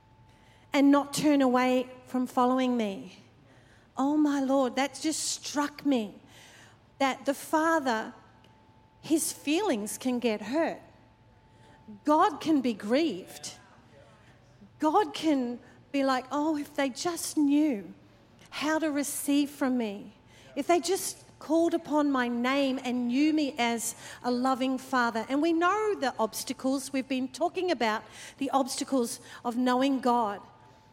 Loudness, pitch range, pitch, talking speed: -28 LUFS, 220-290 Hz, 260 Hz, 130 wpm